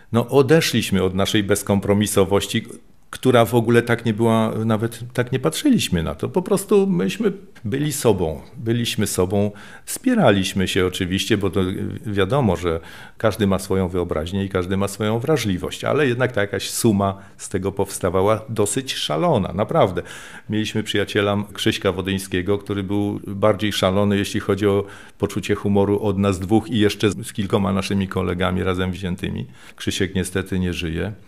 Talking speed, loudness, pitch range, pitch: 150 wpm, -20 LUFS, 95-115 Hz, 100 Hz